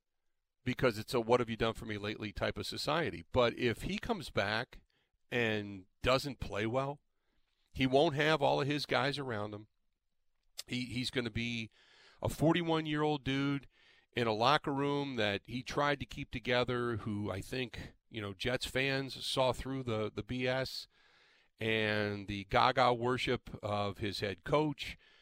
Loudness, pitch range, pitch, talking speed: -34 LUFS, 105-135 Hz, 125 Hz, 170 wpm